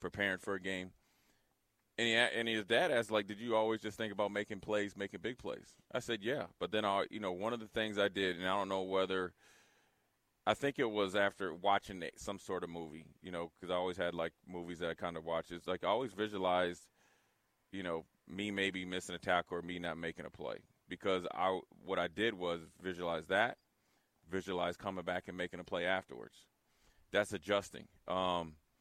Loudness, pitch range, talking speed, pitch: -38 LUFS, 90-105 Hz, 210 wpm, 95 Hz